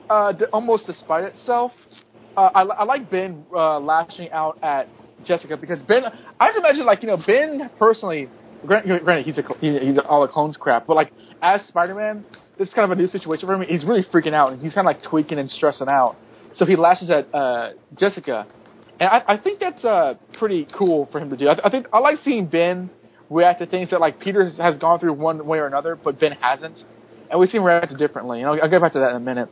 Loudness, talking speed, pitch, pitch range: -19 LUFS, 240 wpm, 175 Hz, 155-200 Hz